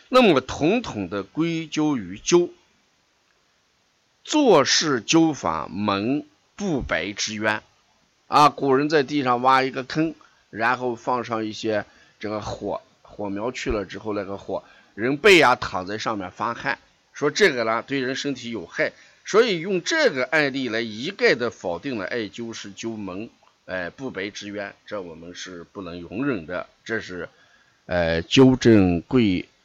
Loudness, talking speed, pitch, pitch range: -22 LUFS, 215 characters per minute, 115 Hz, 100-135 Hz